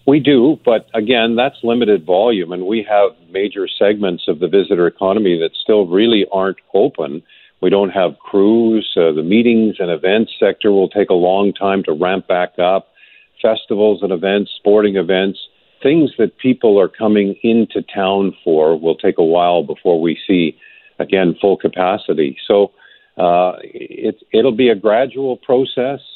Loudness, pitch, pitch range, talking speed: -15 LUFS, 105 Hz, 95-125 Hz, 165 wpm